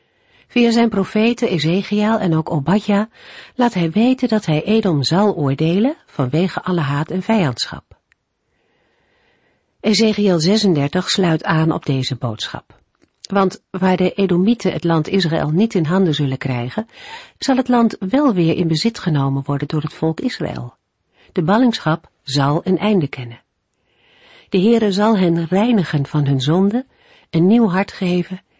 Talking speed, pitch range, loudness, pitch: 145 wpm, 160-215 Hz, -17 LUFS, 185 Hz